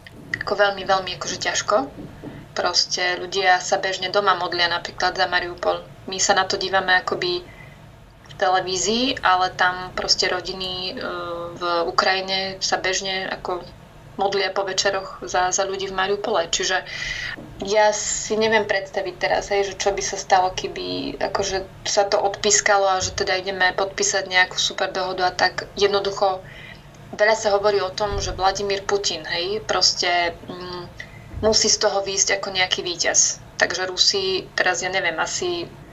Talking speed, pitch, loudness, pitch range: 150 wpm, 190 Hz, -21 LUFS, 180-200 Hz